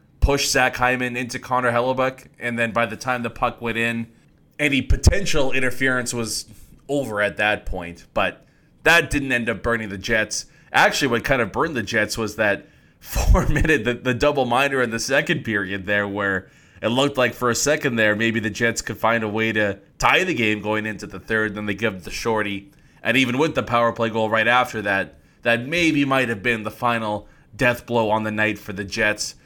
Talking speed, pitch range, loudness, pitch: 210 wpm, 110-130 Hz, -21 LUFS, 115 Hz